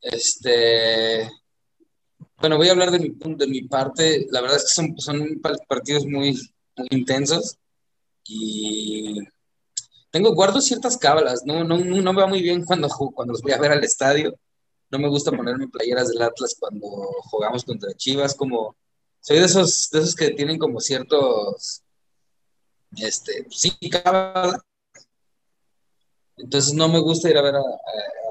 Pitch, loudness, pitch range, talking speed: 155 Hz, -20 LUFS, 135-185 Hz, 155 wpm